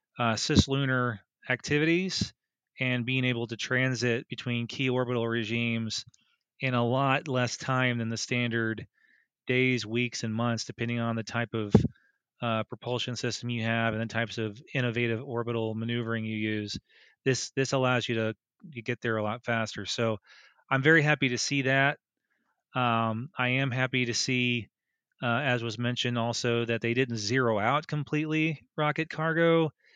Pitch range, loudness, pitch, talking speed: 115-130 Hz, -29 LUFS, 120 Hz, 160 wpm